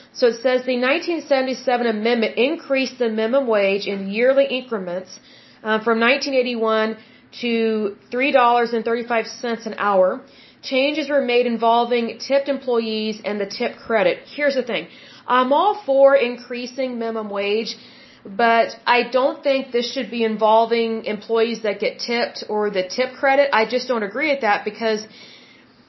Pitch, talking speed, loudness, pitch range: 240 Hz, 145 wpm, -20 LUFS, 220-260 Hz